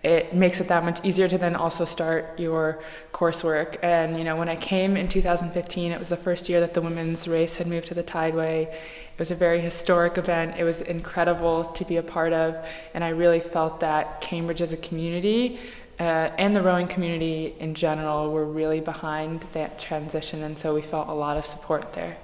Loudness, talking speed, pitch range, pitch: -25 LUFS, 210 wpm, 160-175 Hz, 165 Hz